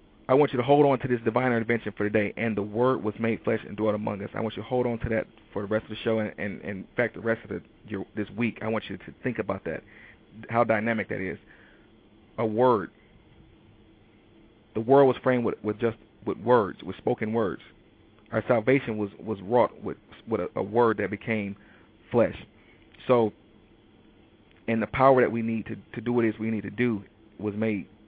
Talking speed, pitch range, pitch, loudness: 225 wpm, 105-115 Hz, 110 Hz, -27 LUFS